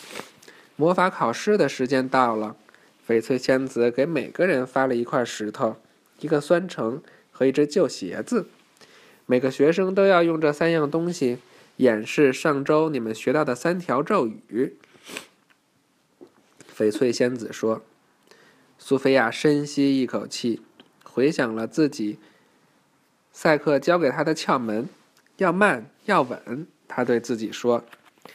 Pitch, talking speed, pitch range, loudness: 135 Hz, 195 characters per minute, 120-155 Hz, -23 LUFS